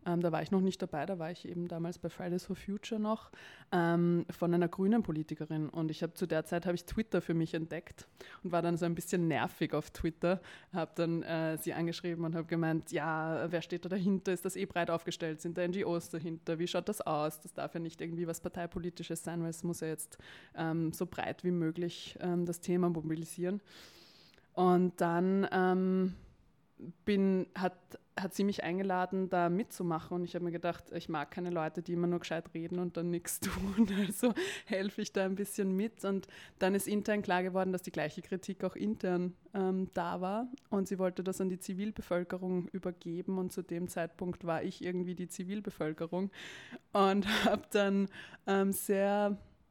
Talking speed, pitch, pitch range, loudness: 200 wpm, 180 Hz, 170-190 Hz, -35 LUFS